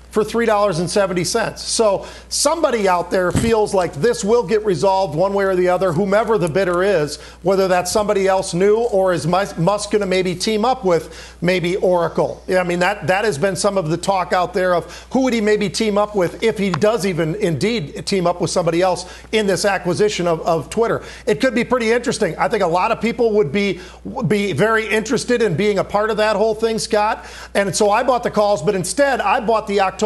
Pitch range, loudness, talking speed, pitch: 180-220 Hz, -18 LUFS, 225 wpm, 200 Hz